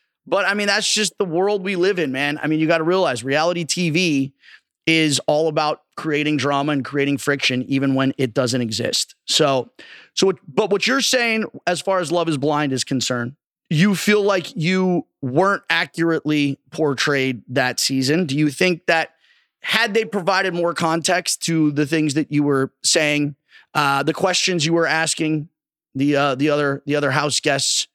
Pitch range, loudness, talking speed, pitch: 140-180 Hz, -19 LUFS, 185 wpm, 155 Hz